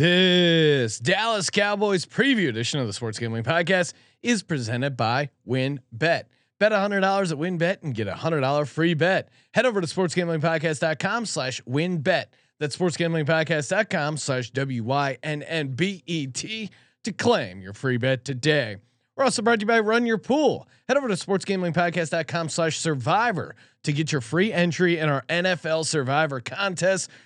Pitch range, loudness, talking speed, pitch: 140-185 Hz, -24 LUFS, 185 wpm, 160 Hz